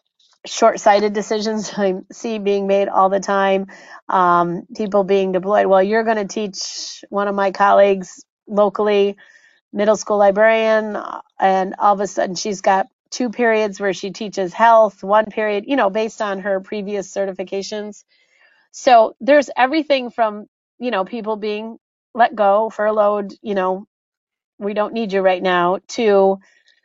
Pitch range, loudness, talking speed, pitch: 195-220 Hz, -17 LUFS, 155 wpm, 210 Hz